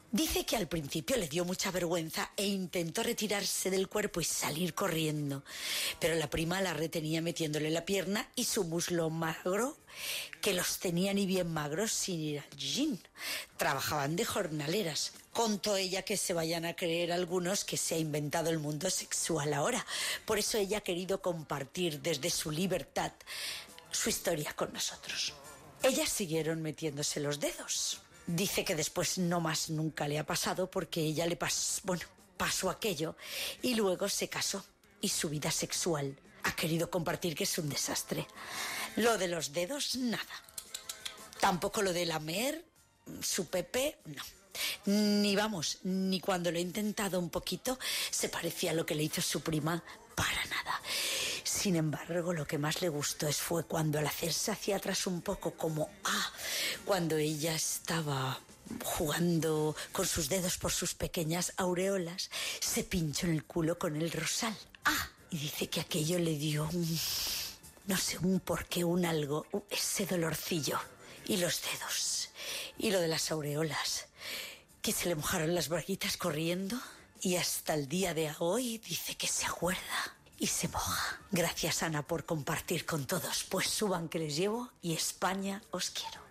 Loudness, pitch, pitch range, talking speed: -34 LUFS, 175 Hz, 160-195 Hz, 165 wpm